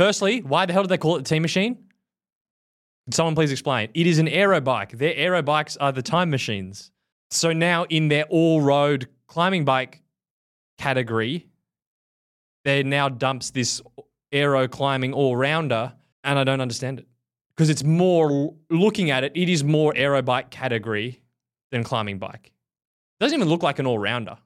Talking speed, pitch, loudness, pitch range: 170 wpm, 140 Hz, -22 LUFS, 125-165 Hz